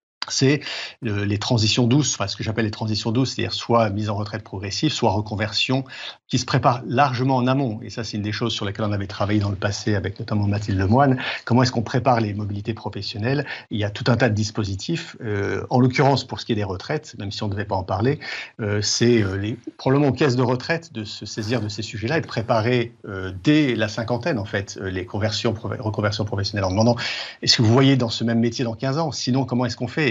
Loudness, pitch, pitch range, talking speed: -22 LUFS, 115 Hz, 105-130 Hz, 245 wpm